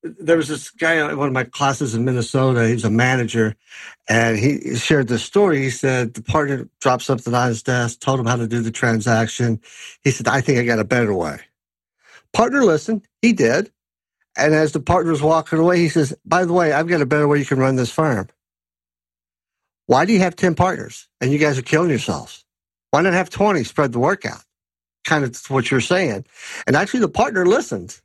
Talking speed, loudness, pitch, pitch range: 210 wpm, -18 LUFS, 135 Hz, 115-160 Hz